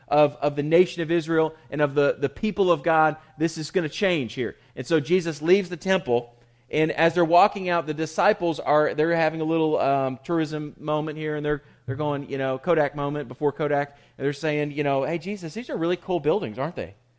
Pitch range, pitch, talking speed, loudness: 145-170 Hz, 155 Hz, 225 wpm, -24 LUFS